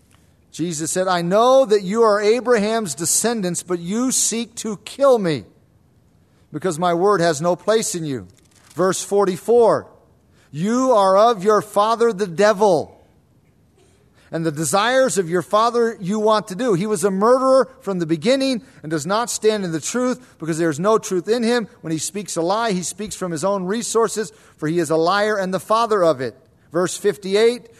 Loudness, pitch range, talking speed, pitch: -19 LUFS, 170-225 Hz, 185 wpm, 200 Hz